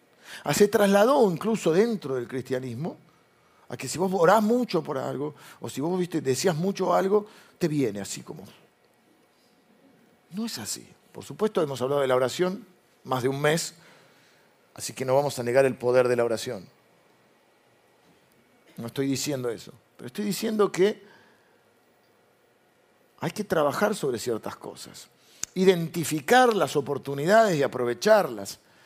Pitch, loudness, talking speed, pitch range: 165 Hz, -25 LUFS, 145 wpm, 135-205 Hz